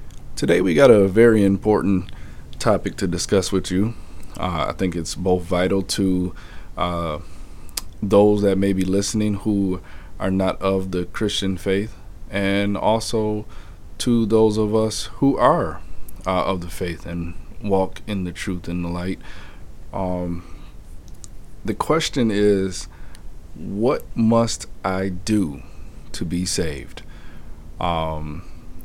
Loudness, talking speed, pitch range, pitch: -21 LUFS, 130 wpm, 85-105 Hz, 95 Hz